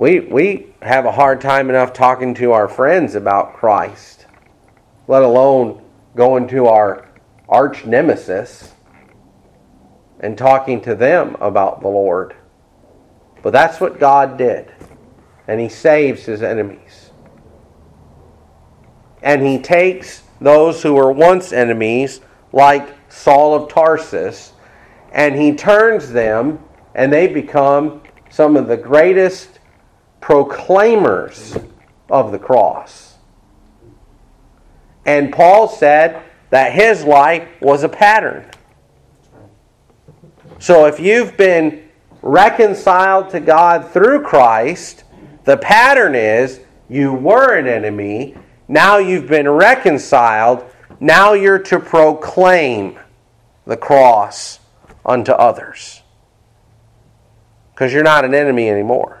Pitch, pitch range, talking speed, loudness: 140 Hz, 120-165 Hz, 110 wpm, -12 LUFS